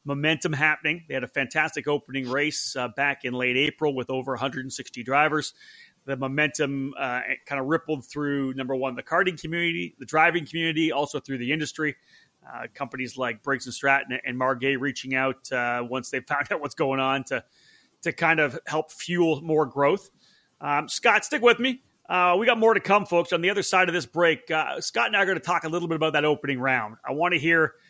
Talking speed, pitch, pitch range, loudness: 215 wpm, 150 Hz, 135-165 Hz, -25 LUFS